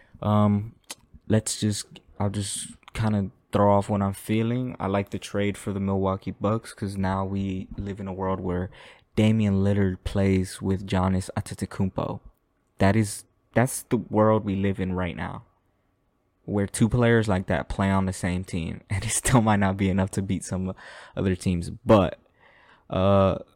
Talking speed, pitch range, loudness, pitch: 175 wpm, 95-105 Hz, -25 LUFS, 100 Hz